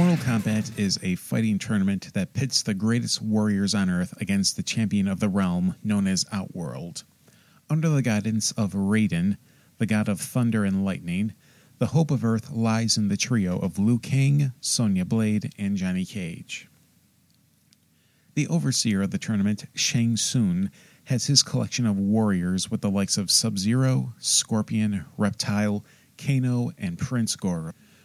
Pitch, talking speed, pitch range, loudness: 110 Hz, 155 wpm, 105-135 Hz, -24 LUFS